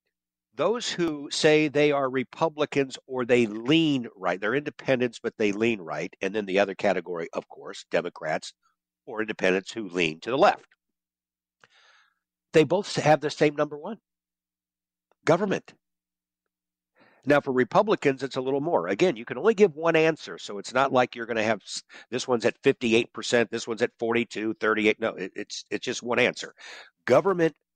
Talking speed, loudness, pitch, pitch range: 165 wpm, -25 LUFS, 120 Hz, 100-150 Hz